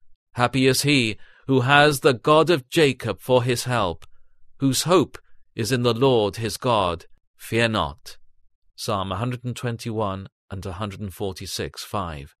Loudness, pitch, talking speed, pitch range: -22 LUFS, 115 Hz, 170 wpm, 95-130 Hz